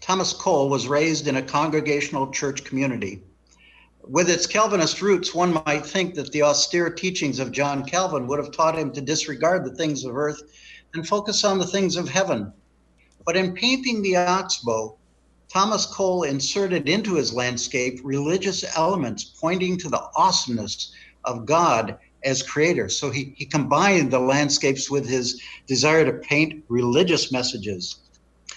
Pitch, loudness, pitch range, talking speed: 150 Hz, -22 LUFS, 135-180 Hz, 155 wpm